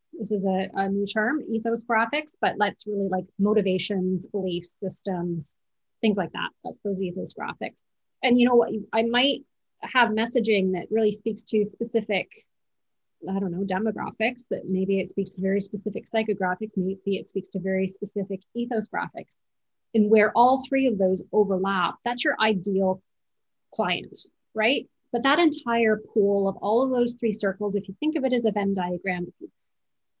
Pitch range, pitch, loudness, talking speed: 190-230 Hz, 210 Hz, -25 LUFS, 170 wpm